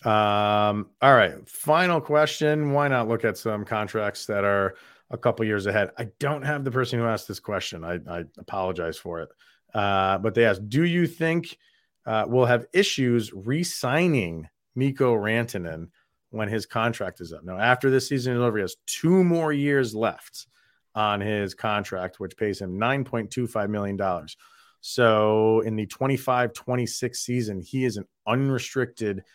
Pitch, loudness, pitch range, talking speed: 115 Hz, -24 LUFS, 105-135 Hz, 165 wpm